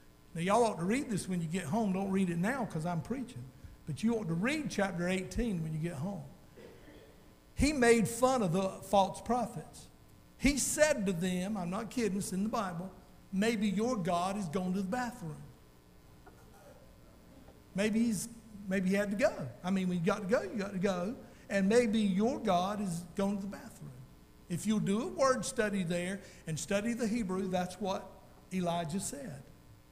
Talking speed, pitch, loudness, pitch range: 195 wpm, 195 Hz, -33 LUFS, 180-225 Hz